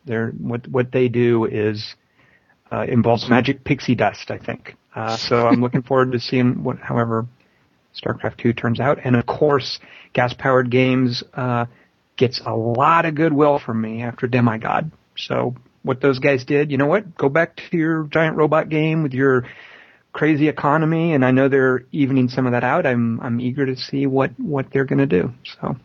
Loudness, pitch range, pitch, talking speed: -19 LUFS, 120-145 Hz, 130 Hz, 190 wpm